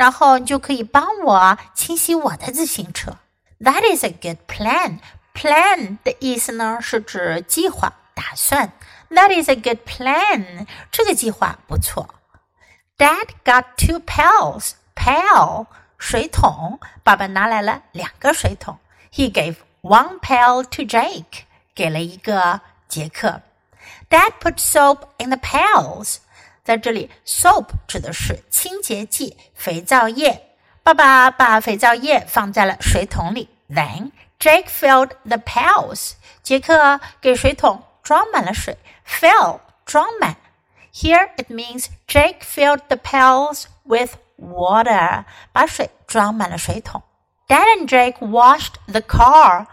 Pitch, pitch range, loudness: 255 Hz, 220-295 Hz, -16 LUFS